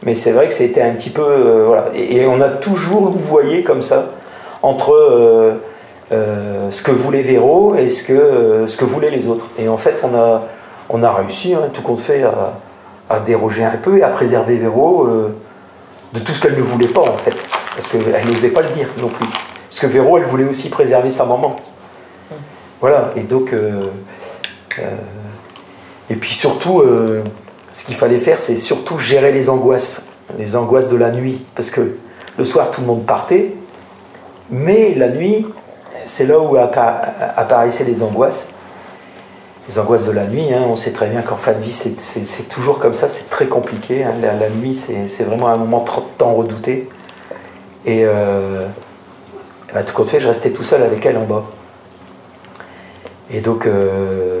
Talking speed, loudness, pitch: 195 wpm, -14 LUFS, 120 Hz